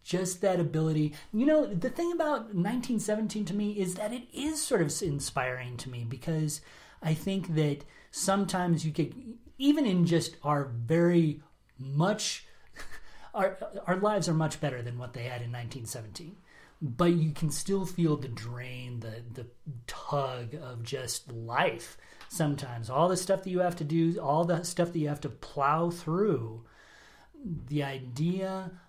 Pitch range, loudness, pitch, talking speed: 140-195 Hz, -31 LUFS, 165 Hz, 160 wpm